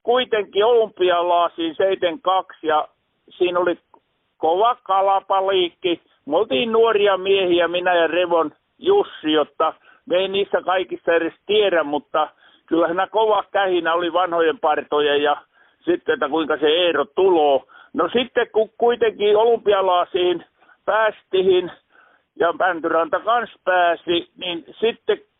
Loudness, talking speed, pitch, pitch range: -19 LUFS, 120 wpm, 195 Hz, 170-235 Hz